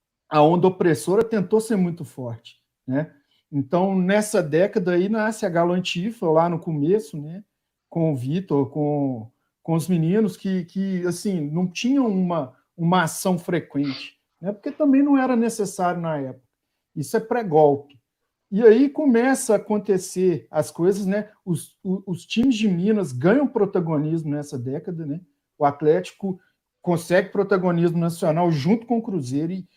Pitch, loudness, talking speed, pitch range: 180 Hz, -22 LUFS, 150 wpm, 155-205 Hz